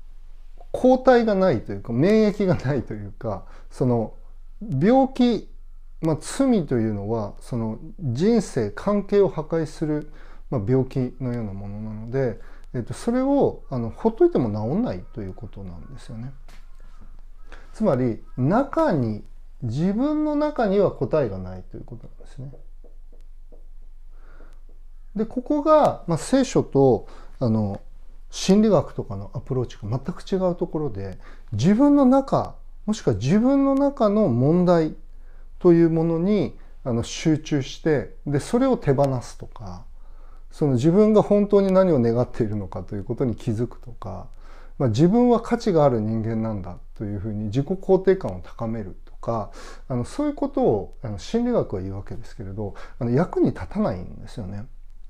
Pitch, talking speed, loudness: 130 Hz, 285 characters per minute, -22 LUFS